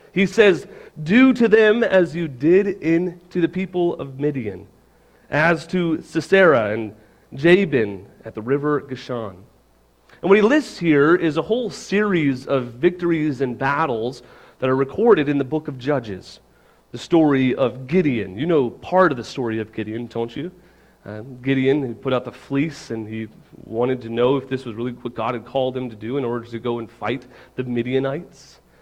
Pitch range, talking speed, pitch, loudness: 120-170 Hz, 185 wpm, 135 Hz, -20 LUFS